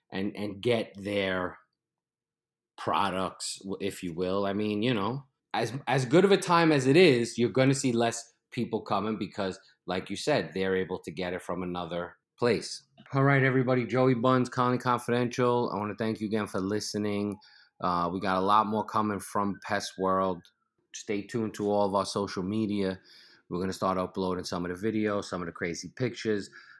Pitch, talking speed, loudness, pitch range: 105 Hz, 190 wpm, -29 LUFS, 95-120 Hz